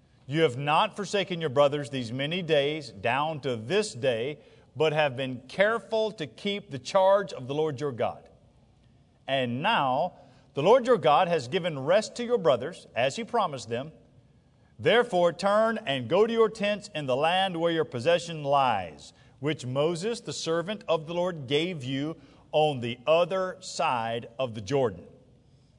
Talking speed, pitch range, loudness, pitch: 170 wpm, 135-190 Hz, -27 LUFS, 155 Hz